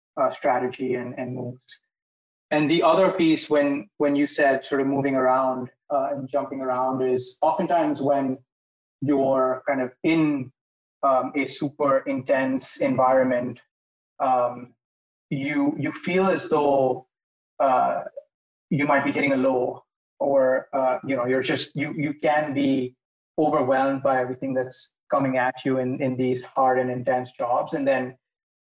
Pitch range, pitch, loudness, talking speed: 130-145 Hz, 135 Hz, -23 LUFS, 150 wpm